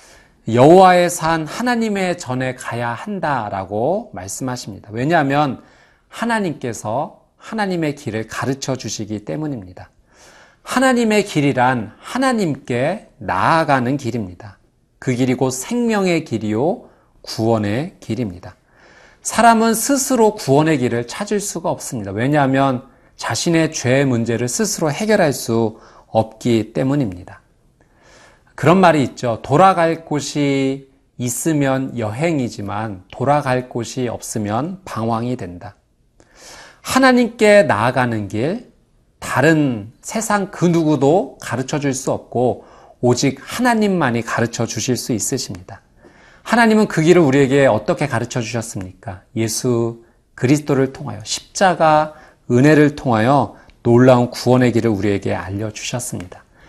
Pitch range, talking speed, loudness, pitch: 115-160 Hz, 280 characters per minute, -17 LUFS, 130 Hz